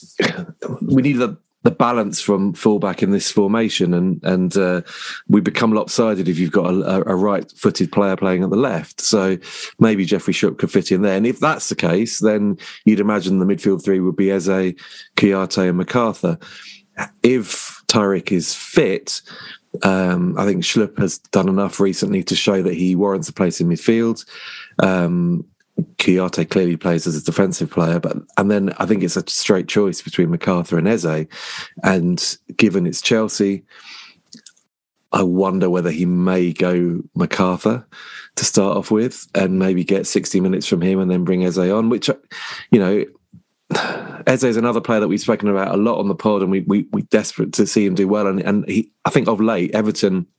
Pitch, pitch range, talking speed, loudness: 95 Hz, 90-105 Hz, 185 wpm, -18 LUFS